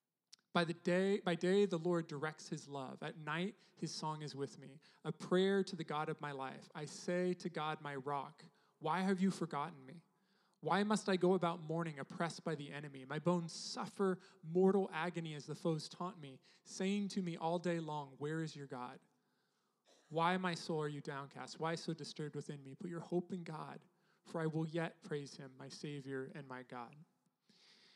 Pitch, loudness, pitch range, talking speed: 165 Hz, -41 LUFS, 150-185 Hz, 200 wpm